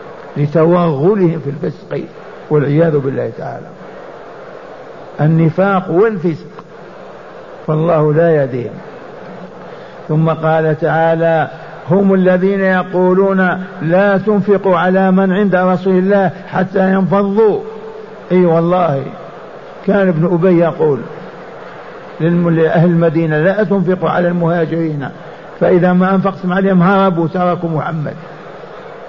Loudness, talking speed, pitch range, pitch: -13 LUFS, 95 wpm, 165-190 Hz, 175 Hz